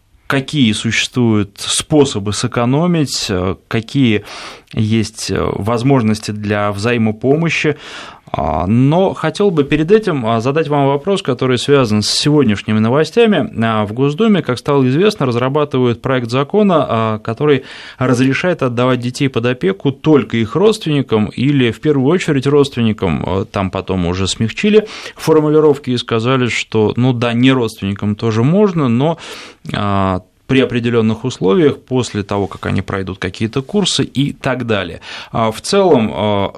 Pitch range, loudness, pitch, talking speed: 110-145 Hz, -14 LUFS, 125 Hz, 120 wpm